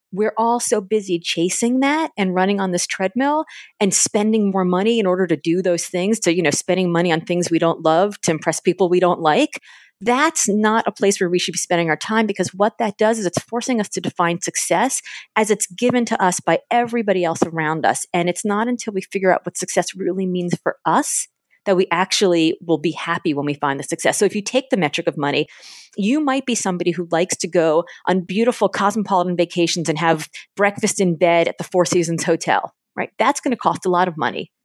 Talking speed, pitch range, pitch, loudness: 230 wpm, 170-215 Hz, 185 Hz, -19 LUFS